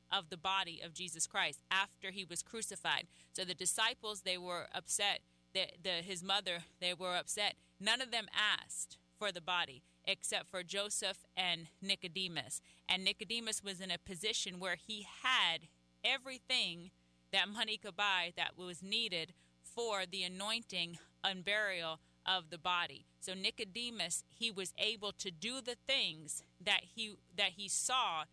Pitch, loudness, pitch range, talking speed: 190 Hz, -38 LUFS, 175-210 Hz, 155 wpm